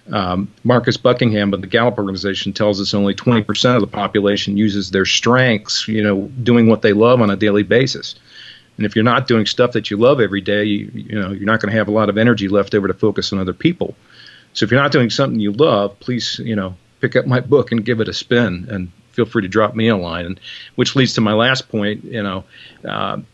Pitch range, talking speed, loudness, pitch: 100-120 Hz, 245 wpm, -16 LUFS, 105 Hz